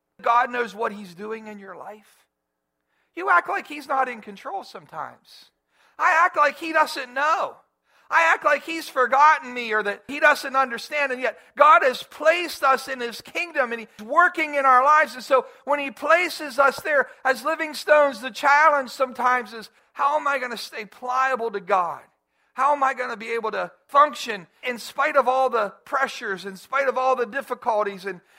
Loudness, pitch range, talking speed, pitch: -21 LUFS, 235-295 Hz, 195 wpm, 265 Hz